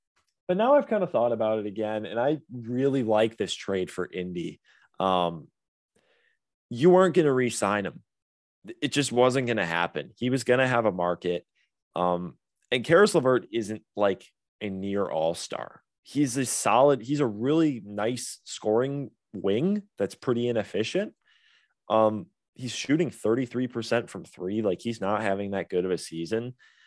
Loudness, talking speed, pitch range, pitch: -26 LUFS, 165 wpm, 100-135 Hz, 120 Hz